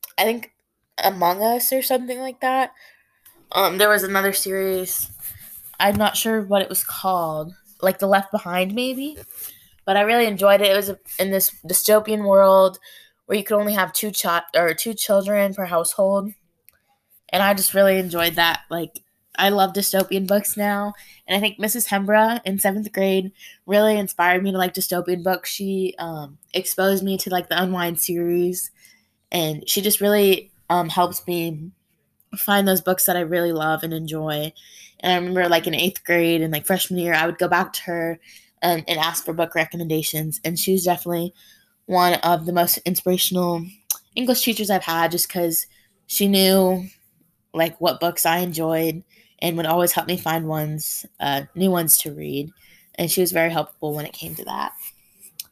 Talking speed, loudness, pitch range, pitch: 180 wpm, -20 LUFS, 170-200 Hz, 185 Hz